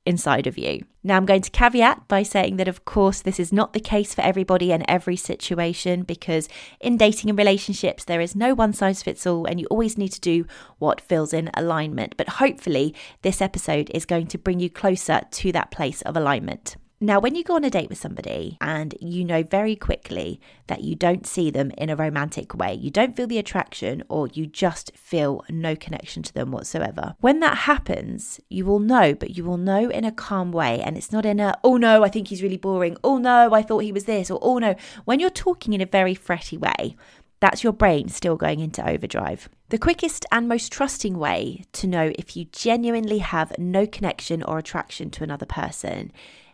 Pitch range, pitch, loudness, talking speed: 170-215 Hz, 190 Hz, -22 LUFS, 215 wpm